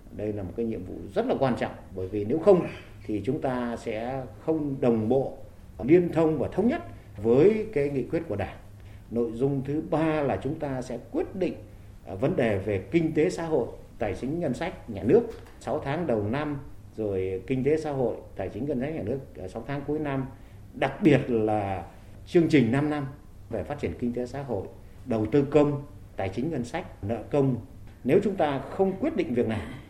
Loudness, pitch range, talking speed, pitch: -27 LUFS, 100-140 Hz, 210 wpm, 120 Hz